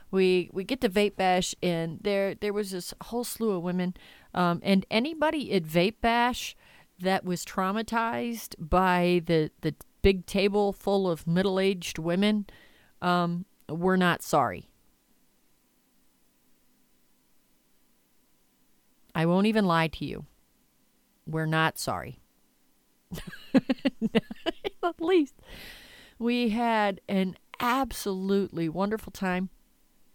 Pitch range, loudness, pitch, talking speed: 180-225 Hz, -28 LUFS, 195 Hz, 110 wpm